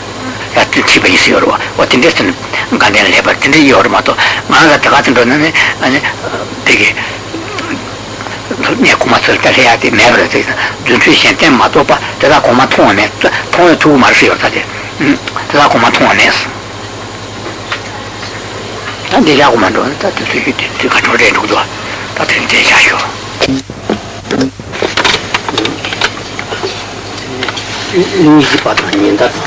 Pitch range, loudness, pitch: 105-135 Hz, -8 LUFS, 105 Hz